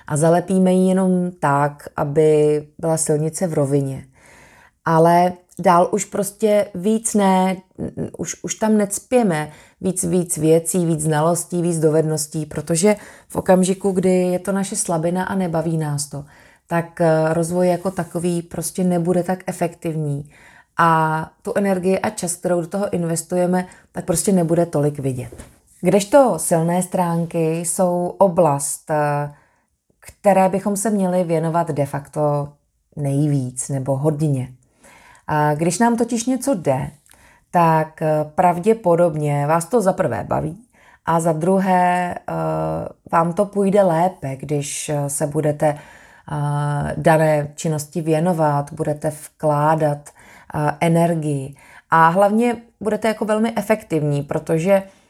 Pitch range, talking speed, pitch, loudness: 150-185 Hz, 120 wpm, 170 Hz, -19 LUFS